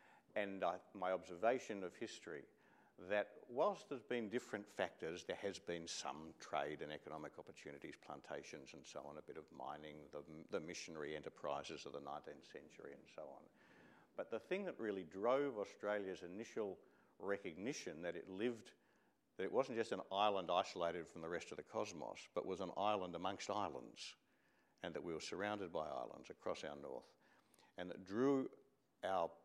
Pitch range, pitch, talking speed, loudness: 85-110 Hz, 95 Hz, 170 wpm, -46 LUFS